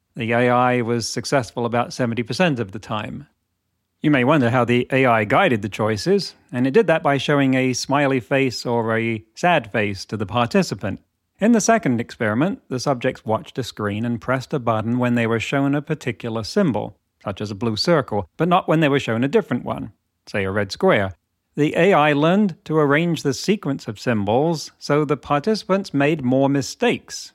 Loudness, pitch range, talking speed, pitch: -20 LUFS, 115-150 Hz, 190 wpm, 130 Hz